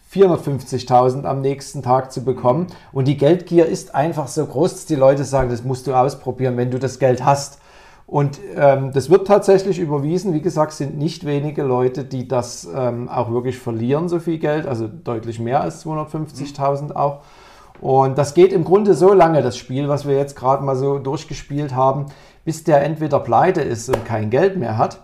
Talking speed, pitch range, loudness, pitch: 190 wpm, 130-155 Hz, -18 LUFS, 140 Hz